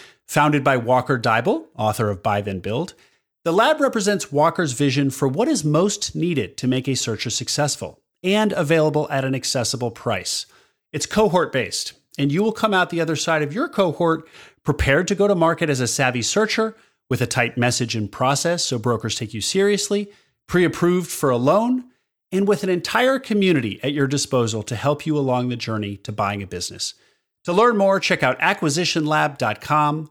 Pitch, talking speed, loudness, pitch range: 150 Hz, 185 wpm, -20 LUFS, 125-185 Hz